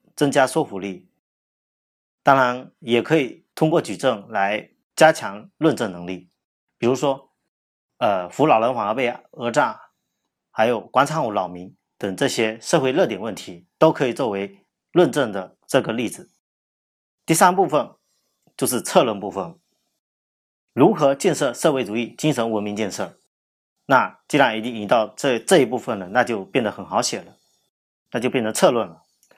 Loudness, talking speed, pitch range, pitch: -21 LUFS, 230 characters per minute, 95-140 Hz, 115 Hz